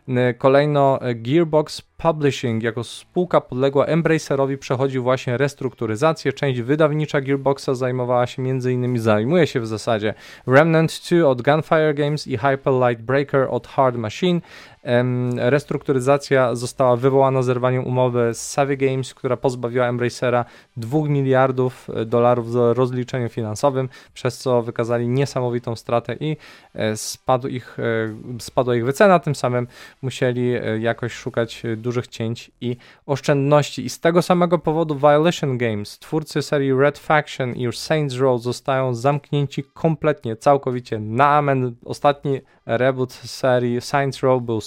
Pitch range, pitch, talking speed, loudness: 120-145 Hz, 130 Hz, 130 wpm, -20 LUFS